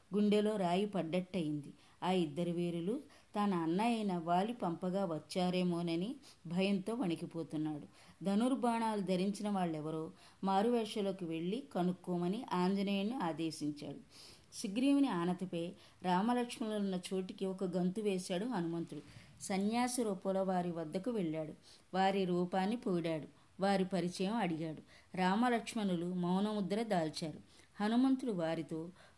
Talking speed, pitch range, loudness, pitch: 95 wpm, 170-210 Hz, -37 LUFS, 185 Hz